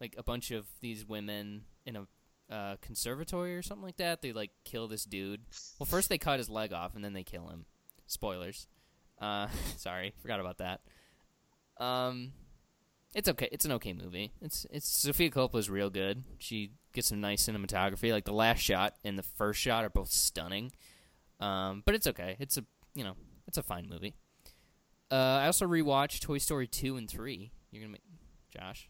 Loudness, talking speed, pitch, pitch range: -34 LUFS, 190 wpm, 110 Hz, 100-135 Hz